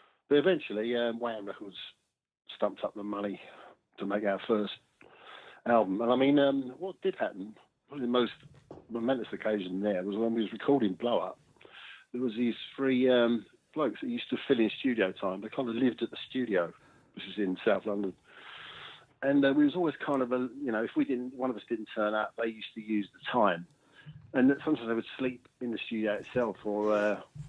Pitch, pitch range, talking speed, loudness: 120 Hz, 105-135 Hz, 205 wpm, -31 LUFS